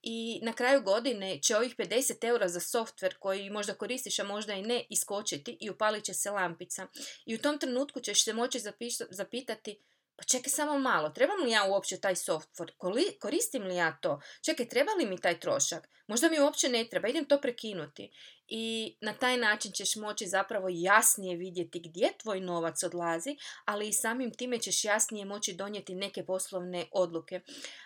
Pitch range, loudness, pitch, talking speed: 190-245 Hz, -31 LUFS, 210 Hz, 180 wpm